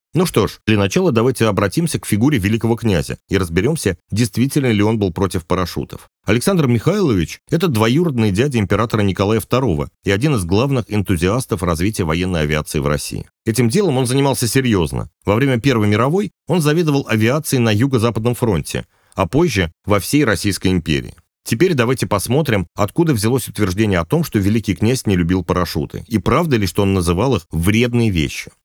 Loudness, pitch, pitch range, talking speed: -17 LUFS, 110 Hz, 95-130 Hz, 170 wpm